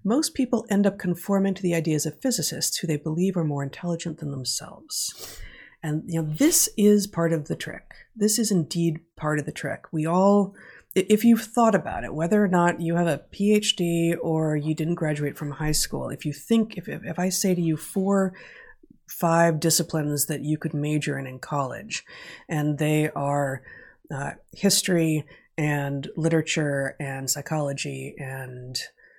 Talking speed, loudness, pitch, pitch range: 175 wpm, -25 LUFS, 165 Hz, 150-195 Hz